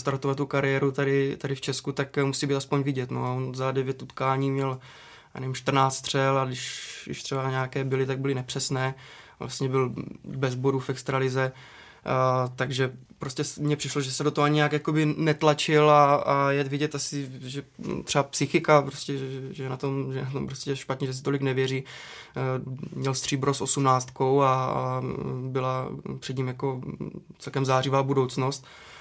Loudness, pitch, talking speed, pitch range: -26 LUFS, 135 Hz, 180 wpm, 130-140 Hz